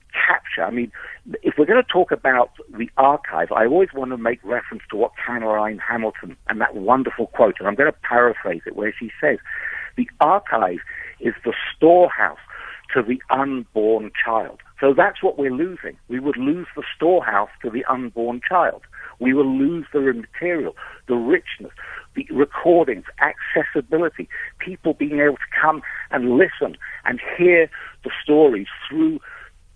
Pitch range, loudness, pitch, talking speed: 120-180 Hz, -20 LUFS, 140 Hz, 160 wpm